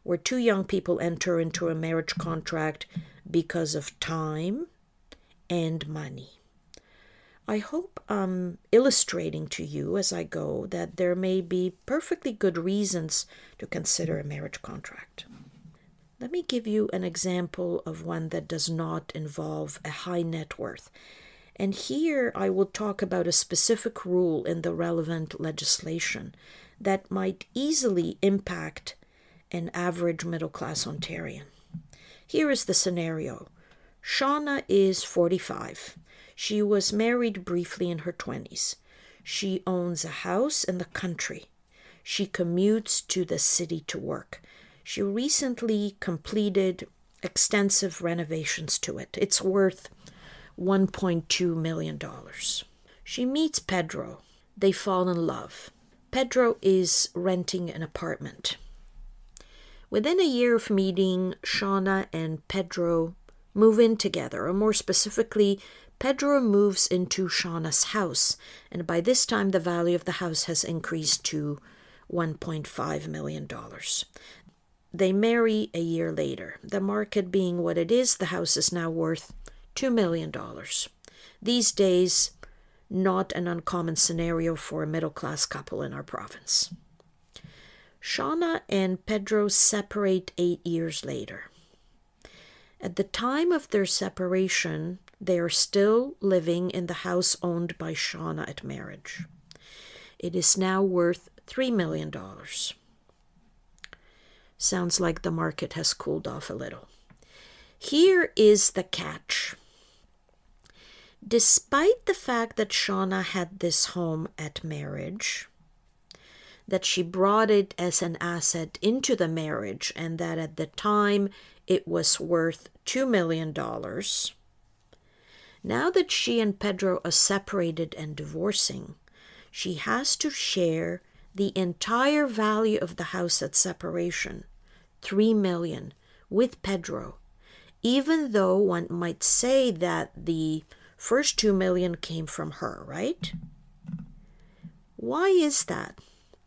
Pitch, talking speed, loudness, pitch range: 180 Hz, 125 wpm, -26 LUFS, 170-205 Hz